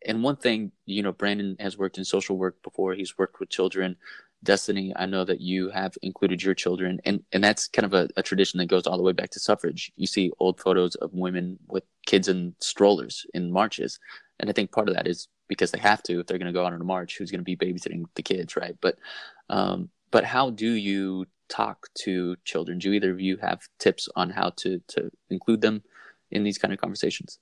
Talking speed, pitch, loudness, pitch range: 235 wpm, 95 Hz, -26 LUFS, 90-100 Hz